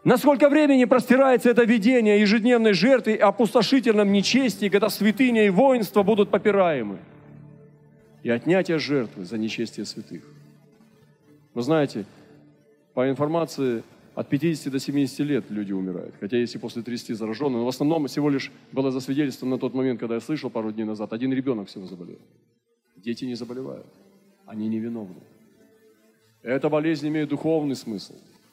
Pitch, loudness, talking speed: 145 Hz, -22 LUFS, 145 wpm